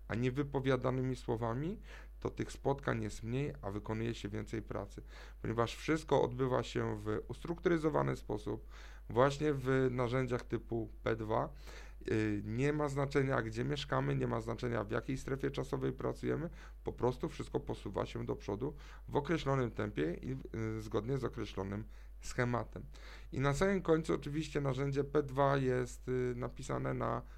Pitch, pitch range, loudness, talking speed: 125 Hz, 110-140 Hz, -37 LUFS, 140 wpm